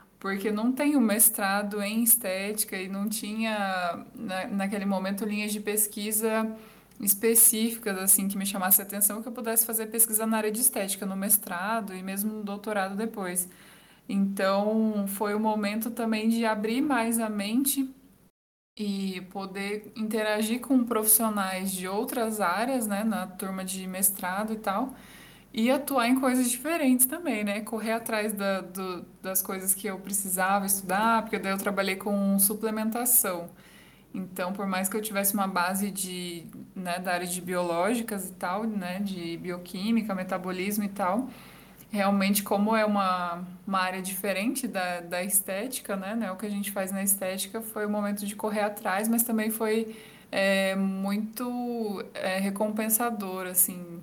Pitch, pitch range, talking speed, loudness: 205 Hz, 190-220 Hz, 155 wpm, -27 LUFS